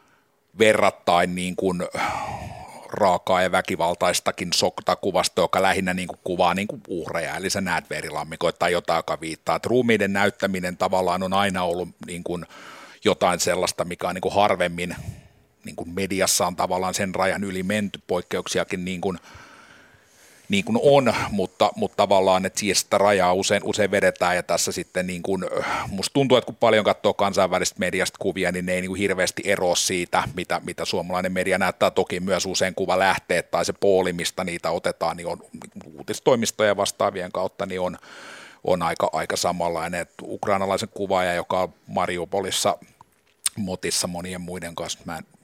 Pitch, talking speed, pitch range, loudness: 90 Hz, 165 wpm, 90-95 Hz, -23 LUFS